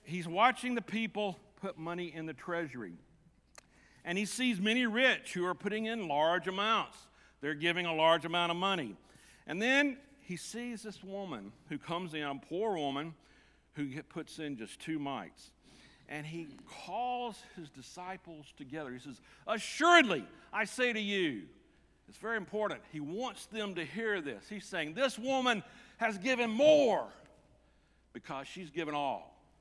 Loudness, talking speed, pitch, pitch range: -34 LUFS, 160 wpm, 185 Hz, 160-230 Hz